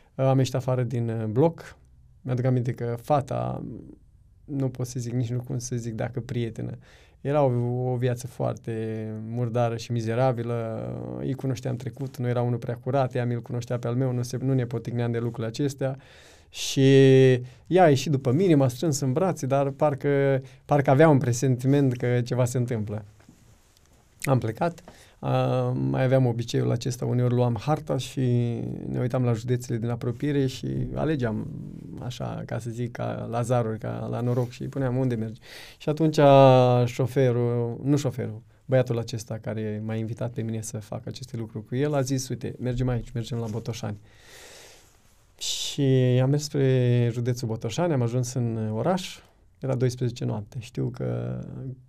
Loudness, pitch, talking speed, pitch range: -25 LUFS, 125 Hz, 170 wpm, 115-135 Hz